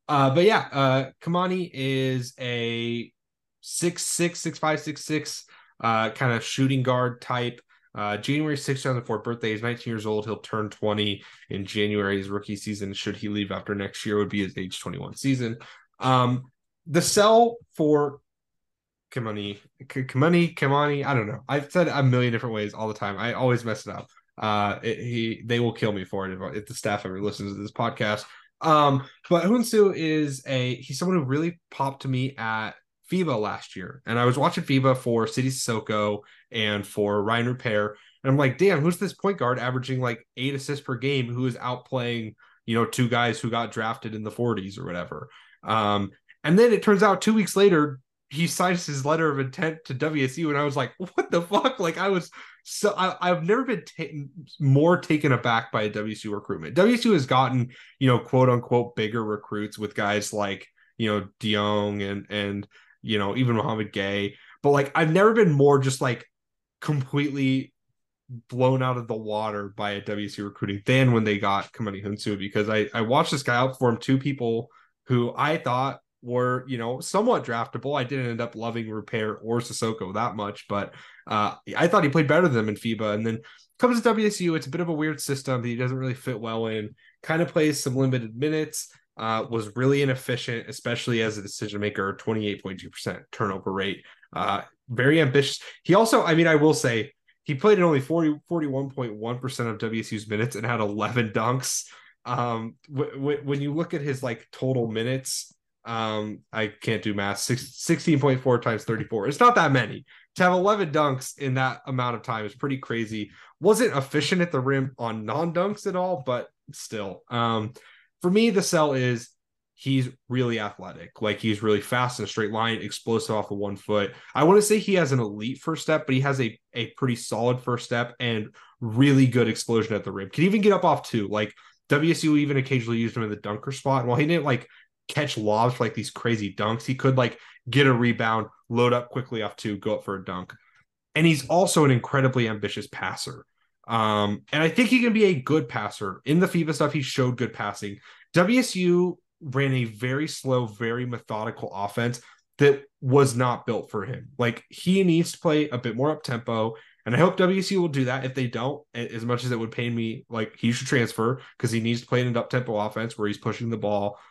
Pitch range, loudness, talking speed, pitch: 110-145 Hz, -25 LUFS, 205 wpm, 125 Hz